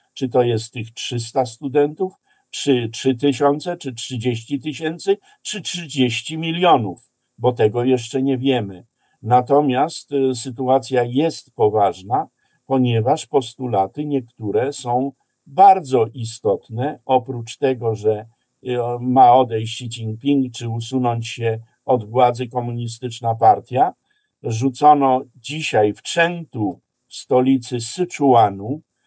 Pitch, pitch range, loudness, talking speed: 130 Hz, 120-145 Hz, -19 LUFS, 105 wpm